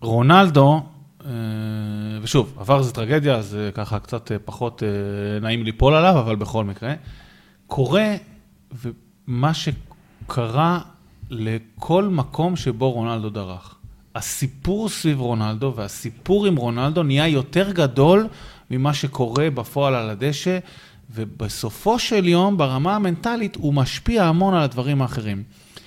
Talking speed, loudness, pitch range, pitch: 110 wpm, -20 LUFS, 110-160 Hz, 130 Hz